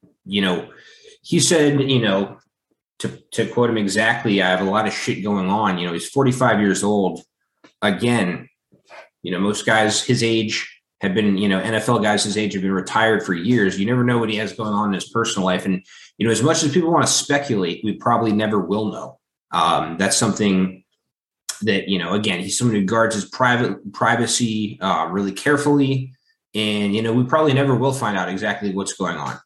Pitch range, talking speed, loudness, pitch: 100-125 Hz, 210 wpm, -19 LUFS, 110 Hz